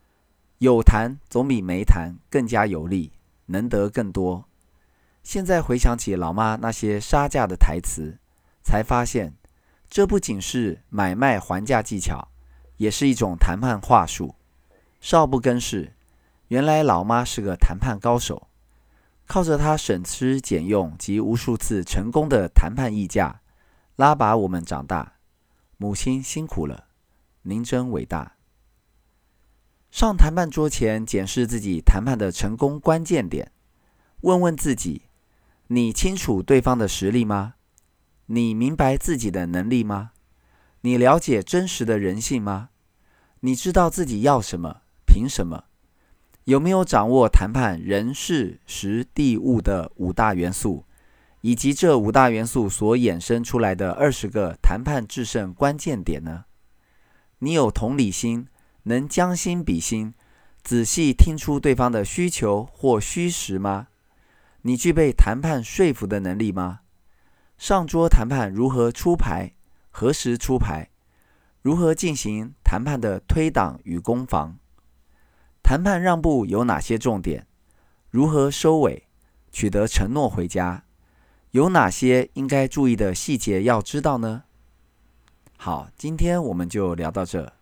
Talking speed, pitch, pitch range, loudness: 205 characters per minute, 110 Hz, 90-135 Hz, -22 LUFS